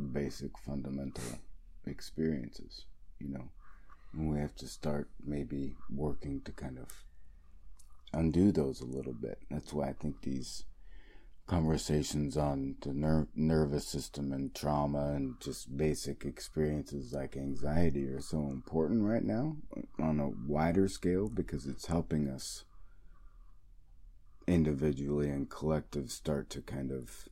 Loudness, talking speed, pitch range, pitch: -36 LUFS, 130 wpm, 70-80 Hz, 75 Hz